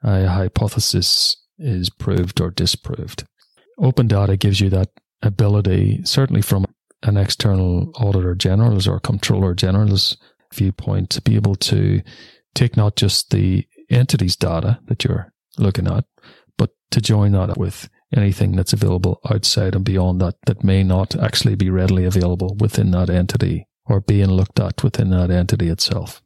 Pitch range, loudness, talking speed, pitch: 95-115 Hz, -18 LUFS, 150 wpm, 100 Hz